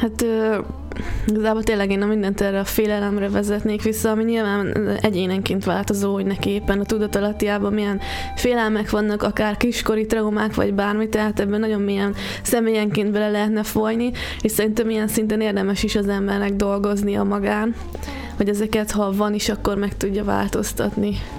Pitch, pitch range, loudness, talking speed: 210 Hz, 200-220 Hz, -21 LUFS, 160 wpm